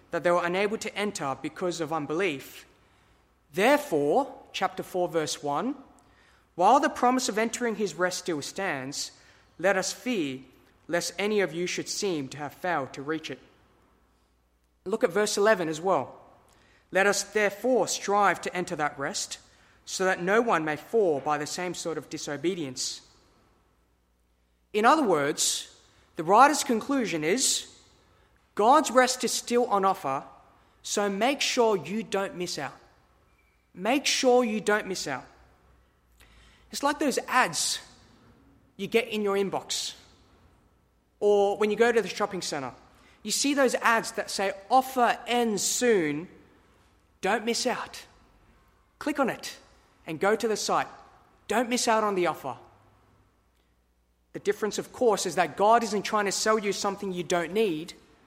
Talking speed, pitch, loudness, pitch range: 155 wpm, 195 Hz, -27 LUFS, 150-225 Hz